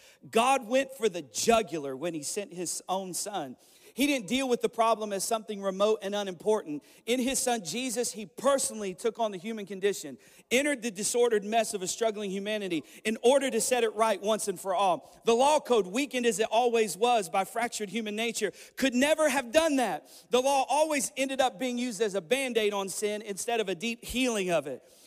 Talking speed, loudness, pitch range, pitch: 210 wpm, -29 LUFS, 205-250 Hz, 225 Hz